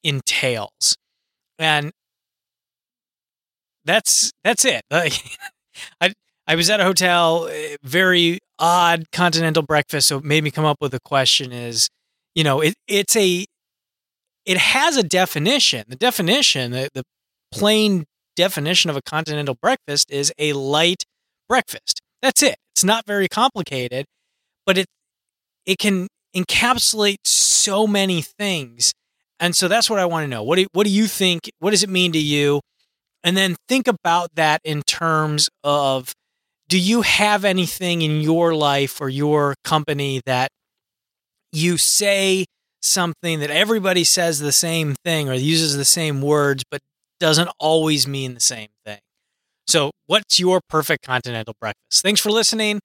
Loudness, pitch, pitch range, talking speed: -18 LUFS, 165 Hz, 145-190 Hz, 150 wpm